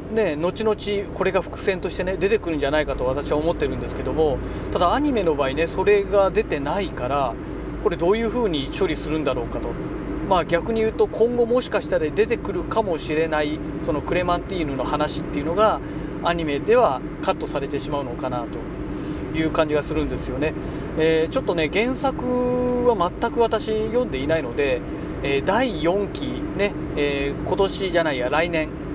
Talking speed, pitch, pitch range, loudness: 370 characters per minute, 170 Hz, 155-215 Hz, -23 LUFS